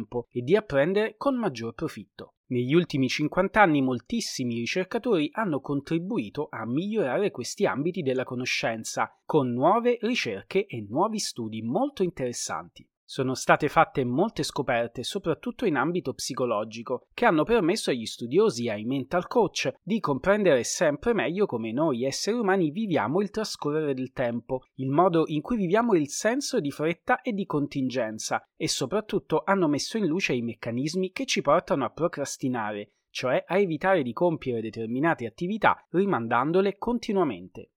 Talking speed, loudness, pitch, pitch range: 150 wpm, -26 LUFS, 160 Hz, 125-200 Hz